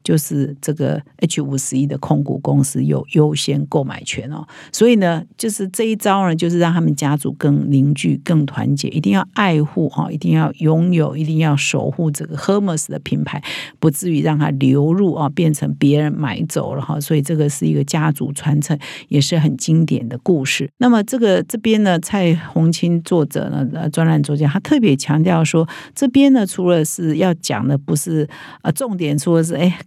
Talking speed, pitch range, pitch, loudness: 295 characters per minute, 145-175 Hz, 155 Hz, -17 LUFS